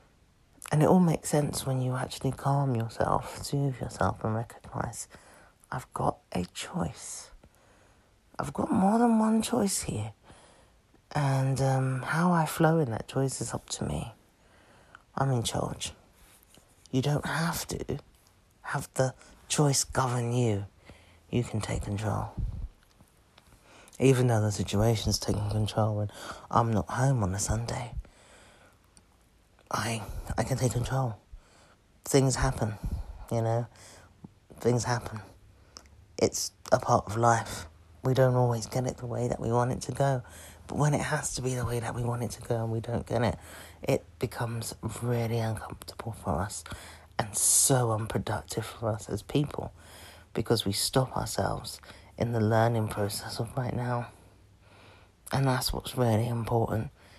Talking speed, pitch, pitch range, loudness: 150 wpm, 115 Hz, 100-130 Hz, -29 LUFS